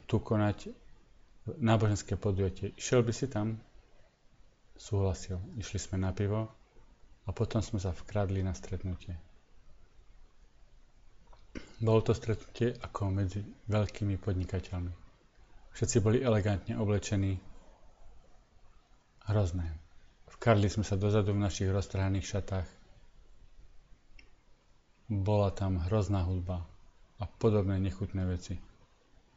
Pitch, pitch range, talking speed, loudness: 100 Hz, 90-105 Hz, 100 wpm, -33 LUFS